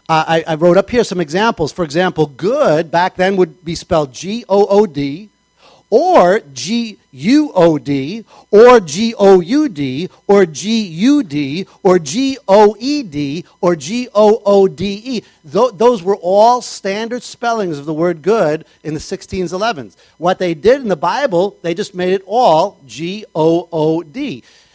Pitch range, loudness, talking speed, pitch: 165-215 Hz, -14 LUFS, 180 wpm, 185 Hz